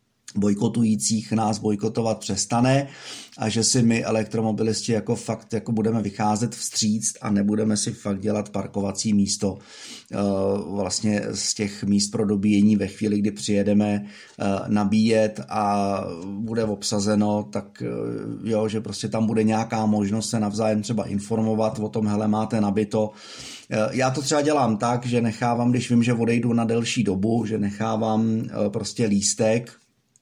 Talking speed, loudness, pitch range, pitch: 140 wpm, -23 LUFS, 105-115 Hz, 110 Hz